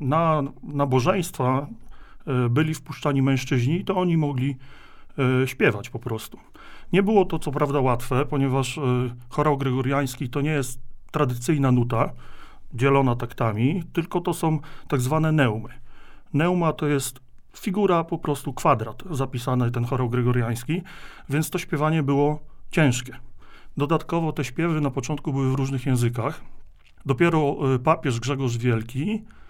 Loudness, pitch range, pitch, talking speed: -24 LUFS, 125-155 Hz, 140 Hz, 125 wpm